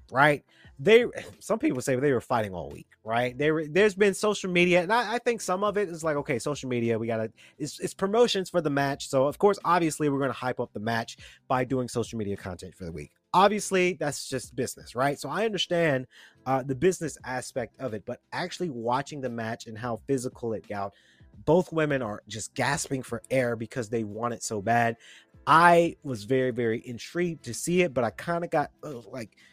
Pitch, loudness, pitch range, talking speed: 135 Hz, -27 LUFS, 115-175 Hz, 215 wpm